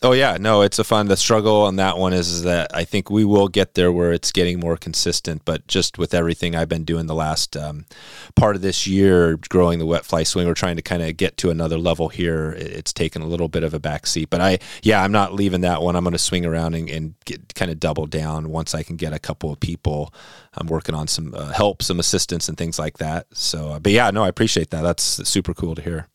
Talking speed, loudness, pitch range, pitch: 260 wpm, -20 LUFS, 80-95 Hz, 85 Hz